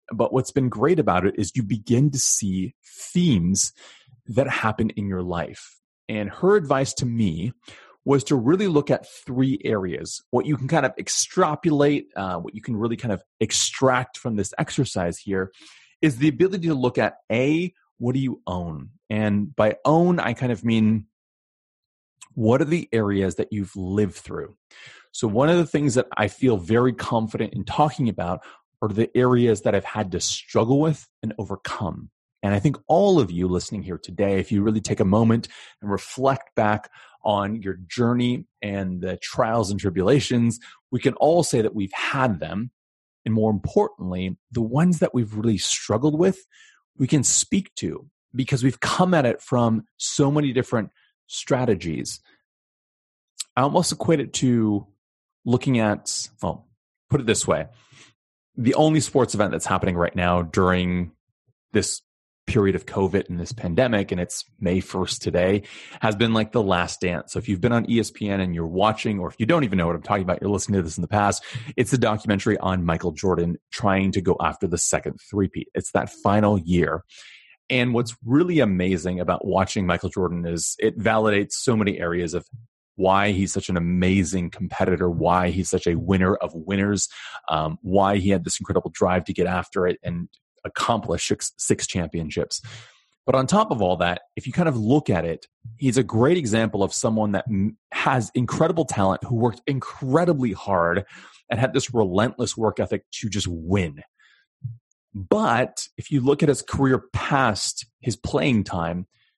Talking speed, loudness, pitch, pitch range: 180 wpm, -23 LUFS, 110 Hz, 95-130 Hz